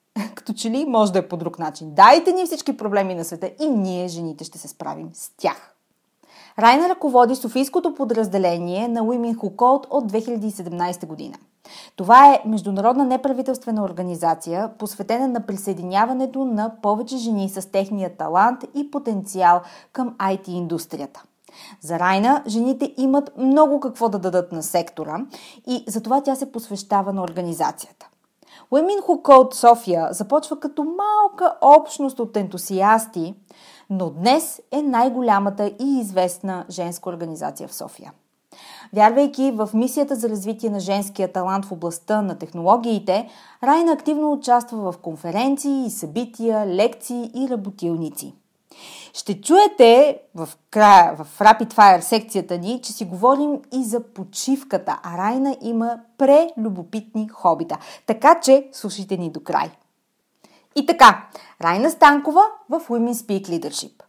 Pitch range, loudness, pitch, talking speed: 185-265 Hz, -19 LUFS, 220 Hz, 135 wpm